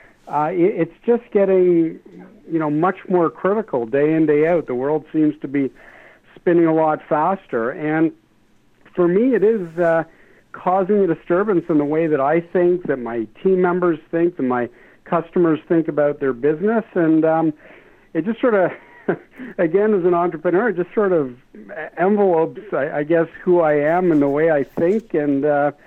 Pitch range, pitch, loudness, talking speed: 150-185 Hz, 165 Hz, -19 LUFS, 175 wpm